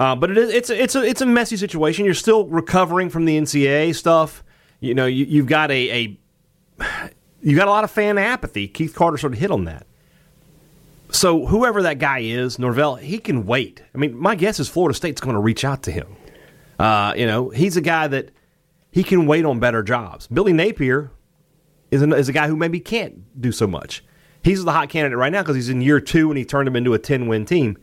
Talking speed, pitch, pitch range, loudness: 235 wpm, 155 Hz, 130-175 Hz, -19 LUFS